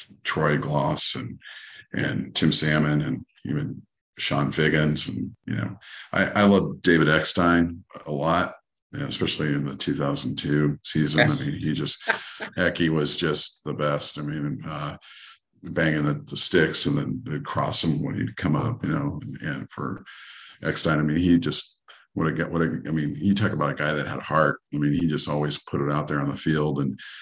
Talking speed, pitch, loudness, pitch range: 205 wpm, 75 Hz, -22 LUFS, 75-80 Hz